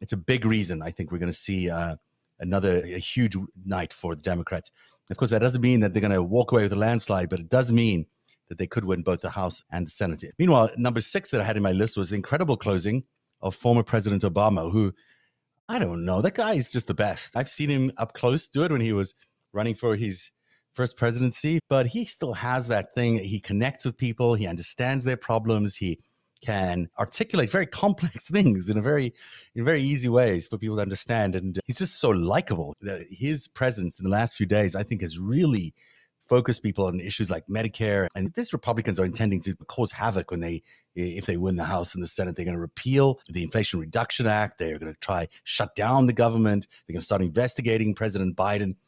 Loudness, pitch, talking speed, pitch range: -26 LUFS, 105 Hz, 225 wpm, 95-125 Hz